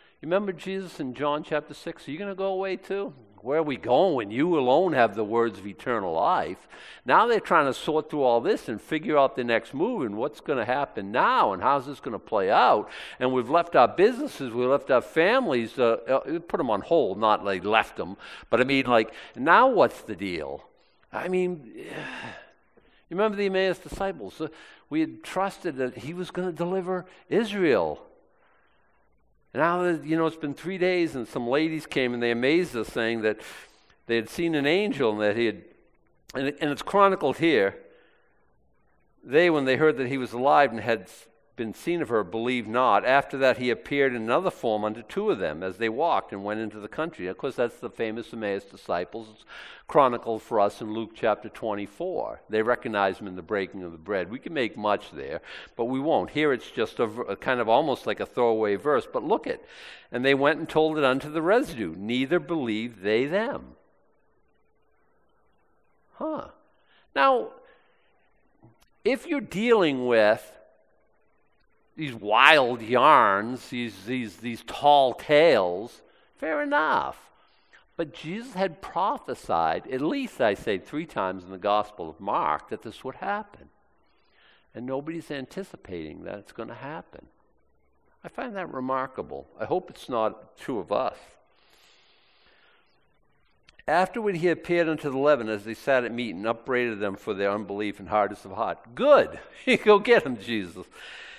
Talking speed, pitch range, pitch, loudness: 180 wpm, 115-170 Hz, 135 Hz, -25 LUFS